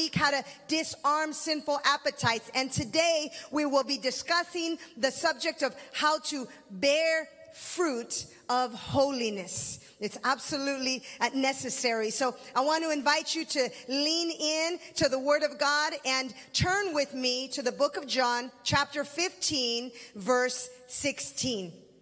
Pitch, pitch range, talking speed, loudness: 275 Hz, 250-305 Hz, 135 wpm, -29 LUFS